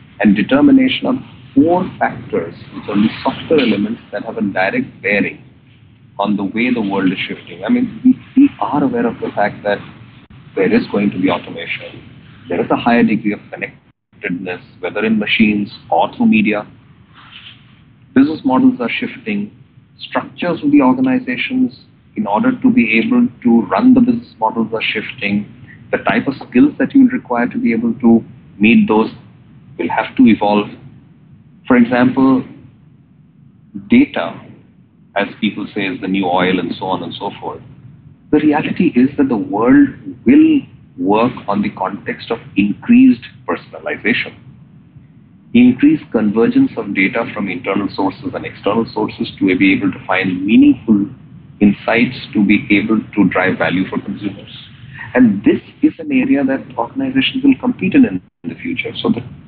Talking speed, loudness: 160 wpm, -15 LUFS